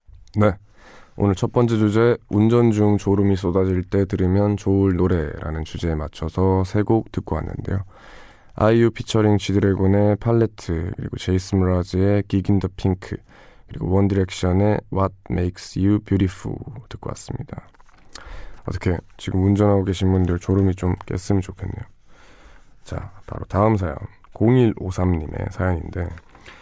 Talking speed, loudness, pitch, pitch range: 320 characters per minute, -21 LUFS, 95 Hz, 90-105 Hz